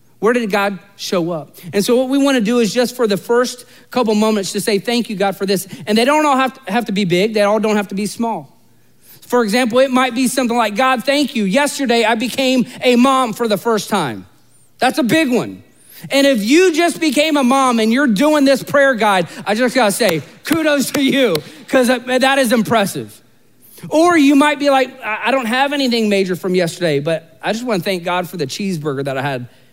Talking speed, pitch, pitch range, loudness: 235 wpm, 230 Hz, 190-260 Hz, -15 LUFS